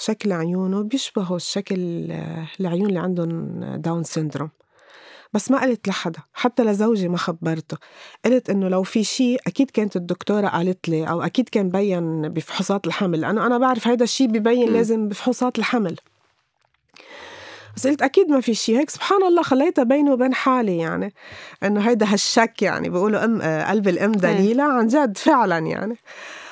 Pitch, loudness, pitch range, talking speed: 210 Hz, -20 LUFS, 180-250 Hz, 155 wpm